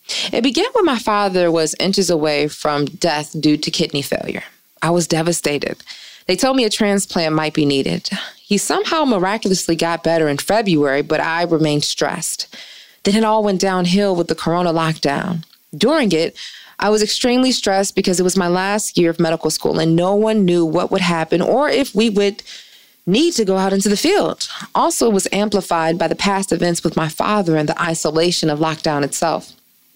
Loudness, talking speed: -17 LUFS, 190 wpm